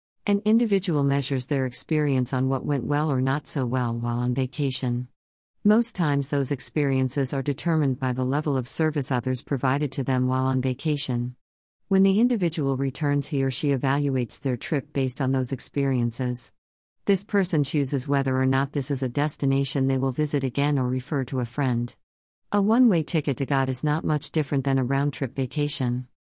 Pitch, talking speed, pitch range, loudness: 135 Hz, 185 wpm, 130-150 Hz, -25 LUFS